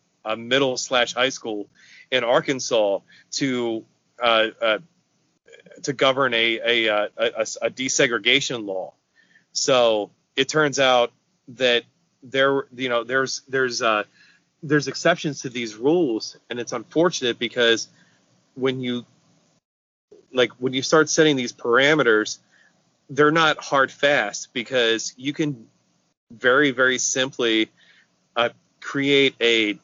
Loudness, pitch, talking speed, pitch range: -21 LUFS, 130 Hz, 125 wpm, 115-140 Hz